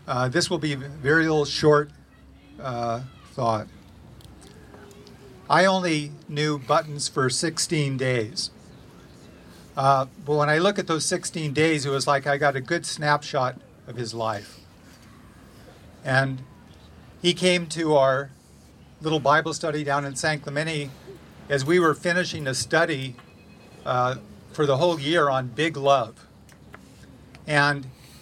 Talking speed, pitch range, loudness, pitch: 135 wpm, 125-155 Hz, -23 LUFS, 145 Hz